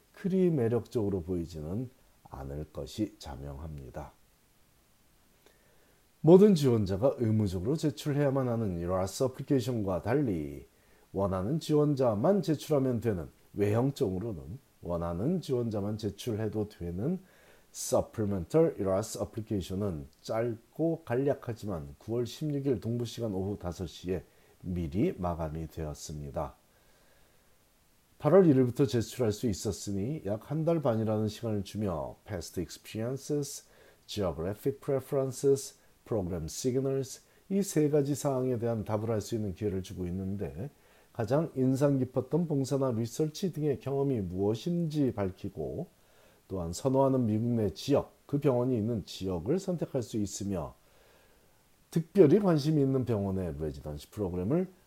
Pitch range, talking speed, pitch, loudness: 95-140 Hz, 320 characters per minute, 115 Hz, -31 LUFS